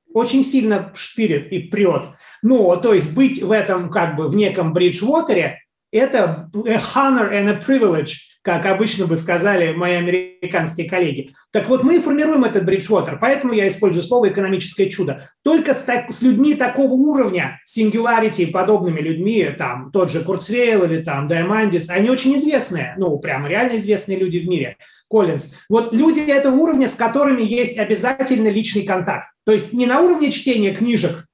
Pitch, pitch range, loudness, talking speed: 210 Hz, 180-250 Hz, -17 LUFS, 170 wpm